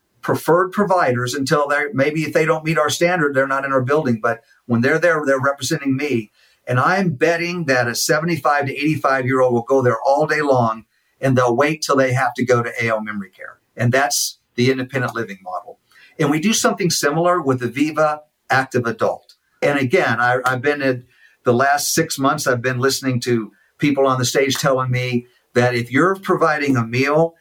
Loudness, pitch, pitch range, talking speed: -18 LUFS, 135 Hz, 125-155 Hz, 205 wpm